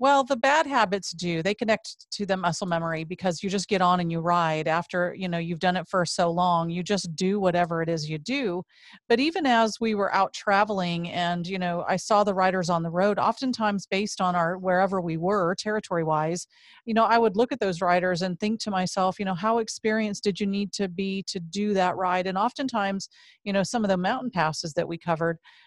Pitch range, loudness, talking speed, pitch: 175-210 Hz, -25 LUFS, 230 wpm, 190 Hz